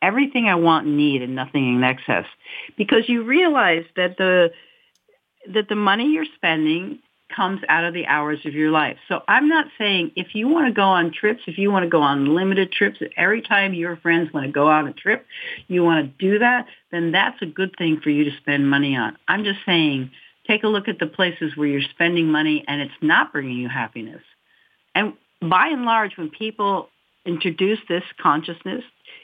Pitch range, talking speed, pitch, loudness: 155-215 Hz, 205 wpm, 175 Hz, -20 LUFS